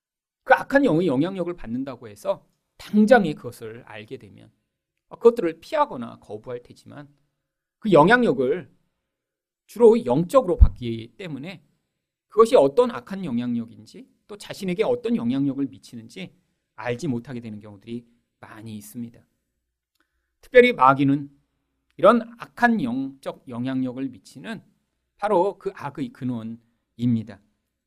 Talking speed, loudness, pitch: 275 characters per minute, -21 LUFS, 135 Hz